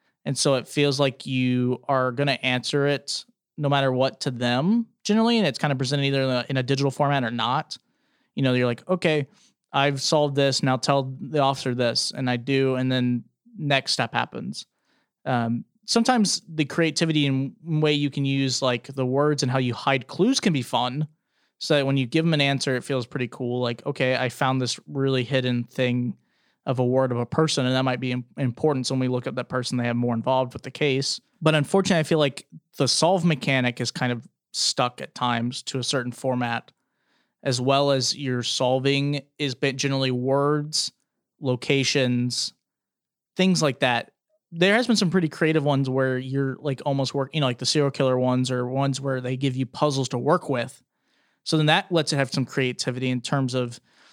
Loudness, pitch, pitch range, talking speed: -24 LUFS, 135 Hz, 125-145 Hz, 205 wpm